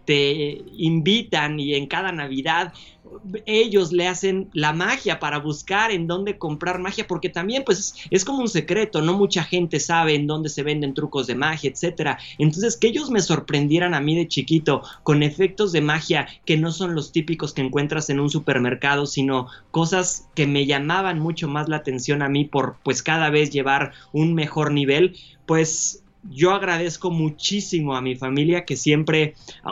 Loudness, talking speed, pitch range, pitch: -21 LUFS, 175 wpm, 145-180 Hz, 155 Hz